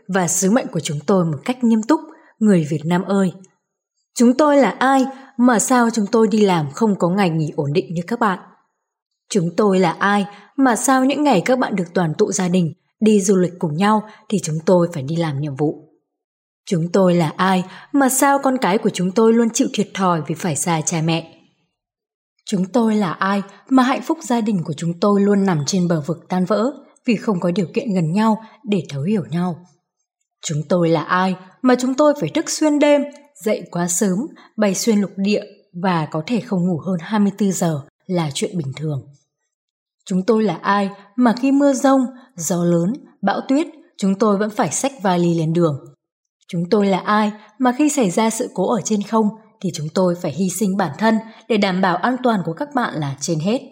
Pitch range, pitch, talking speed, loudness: 175-235 Hz, 200 Hz, 215 wpm, -18 LUFS